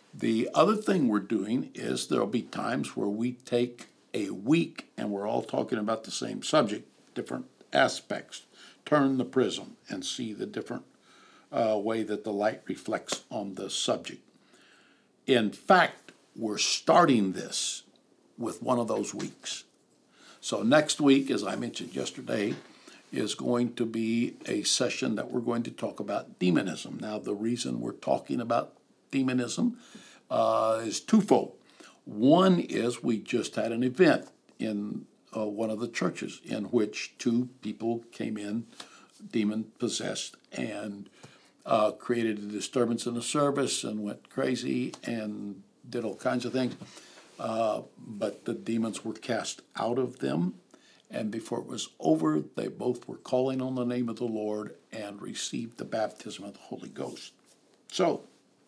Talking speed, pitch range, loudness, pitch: 155 wpm, 105-125 Hz, -30 LUFS, 115 Hz